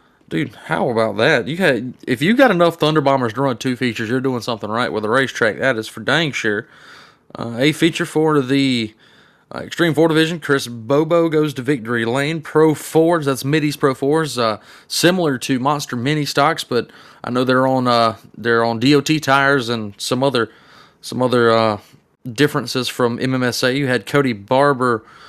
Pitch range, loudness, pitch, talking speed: 120-150 Hz, -17 LUFS, 135 Hz, 185 wpm